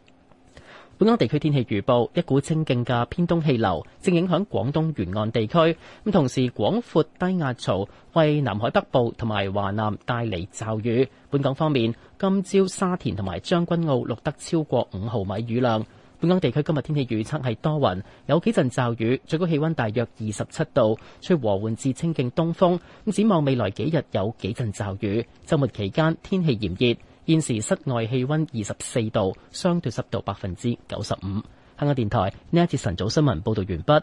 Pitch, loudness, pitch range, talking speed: 125 Hz, -24 LUFS, 110-160 Hz, 285 characters per minute